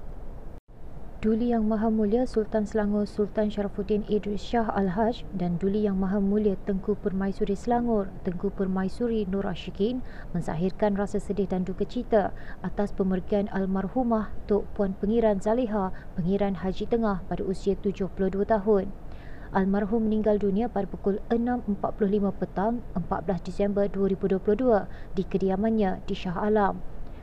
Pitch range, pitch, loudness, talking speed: 190-215 Hz, 205 Hz, -27 LUFS, 130 wpm